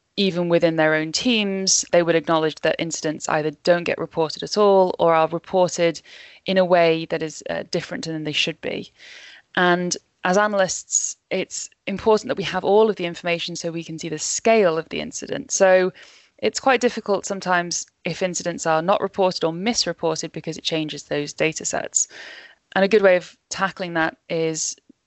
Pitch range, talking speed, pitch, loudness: 160-195 Hz, 185 wpm, 175 Hz, -21 LUFS